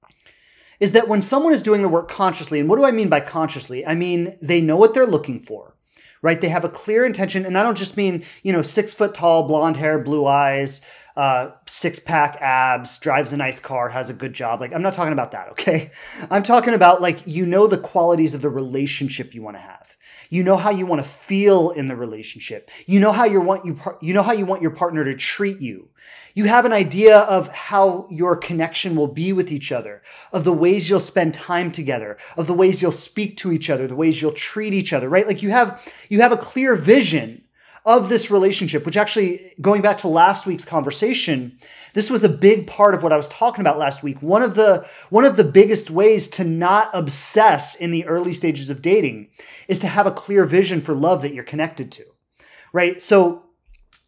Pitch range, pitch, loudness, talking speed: 155-205 Hz, 175 Hz, -18 LUFS, 225 wpm